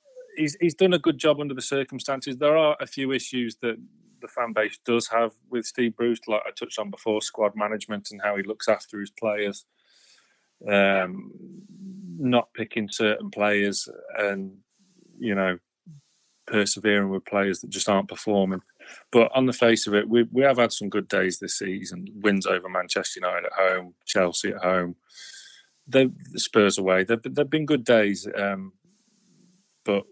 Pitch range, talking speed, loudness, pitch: 100-140 Hz, 175 wpm, -24 LUFS, 115 Hz